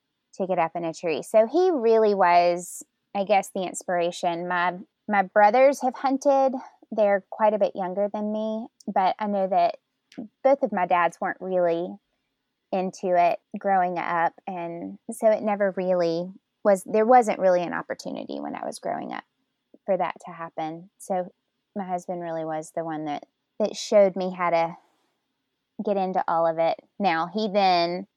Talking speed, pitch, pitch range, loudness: 175 wpm, 195 Hz, 175-220 Hz, -24 LUFS